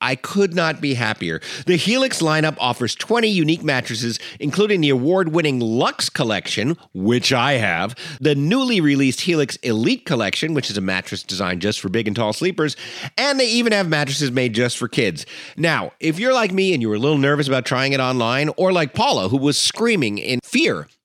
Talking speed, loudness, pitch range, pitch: 195 wpm, -19 LUFS, 120-170 Hz, 140 Hz